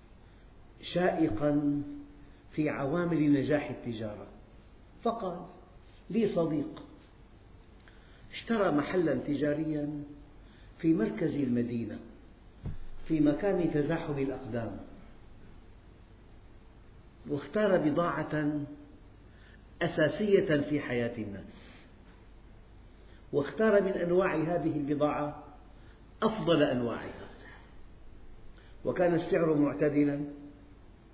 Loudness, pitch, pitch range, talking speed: -31 LUFS, 145 Hz, 105-155 Hz, 65 wpm